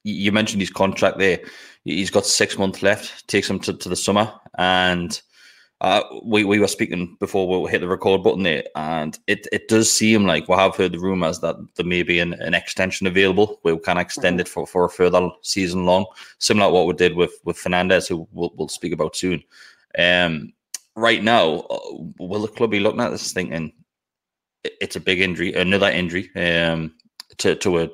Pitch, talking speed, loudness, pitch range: 90 Hz, 205 wpm, -20 LUFS, 90-100 Hz